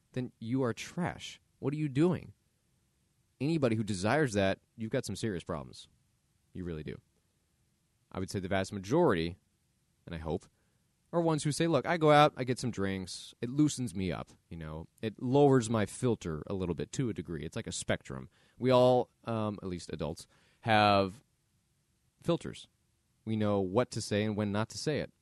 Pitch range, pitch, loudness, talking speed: 100-130 Hz, 110 Hz, -32 LUFS, 195 wpm